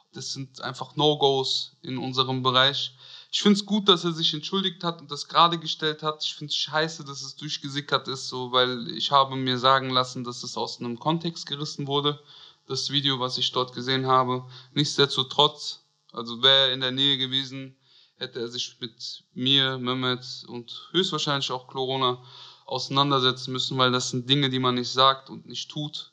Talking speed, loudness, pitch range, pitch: 185 wpm, -24 LUFS, 130-145 Hz, 135 Hz